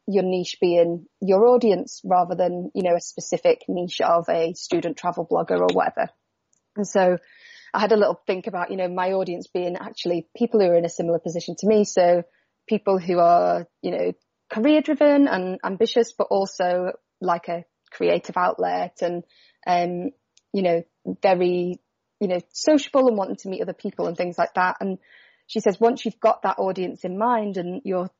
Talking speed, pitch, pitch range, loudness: 185 wpm, 185 Hz, 175-215 Hz, -22 LUFS